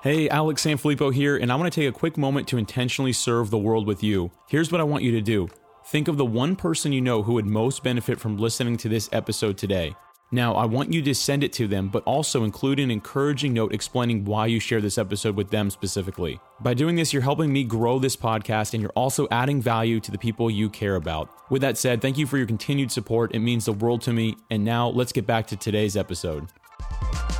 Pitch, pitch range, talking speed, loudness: 115 Hz, 110-135 Hz, 240 wpm, -24 LUFS